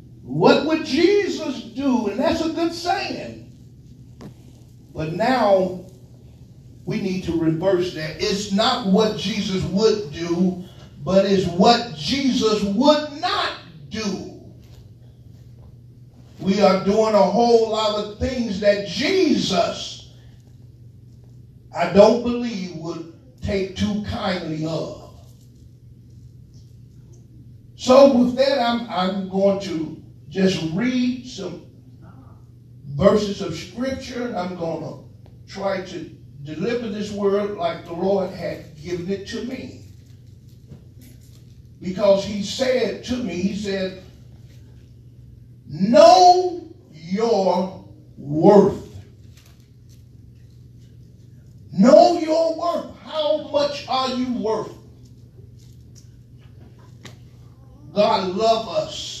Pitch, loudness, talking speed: 180 Hz, -20 LUFS, 100 wpm